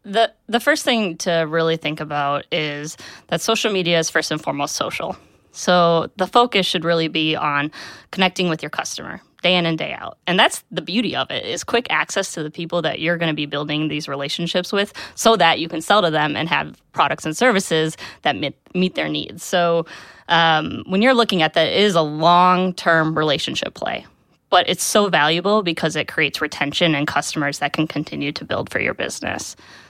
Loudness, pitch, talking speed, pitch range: -19 LUFS, 165 Hz, 205 wpm, 155-190 Hz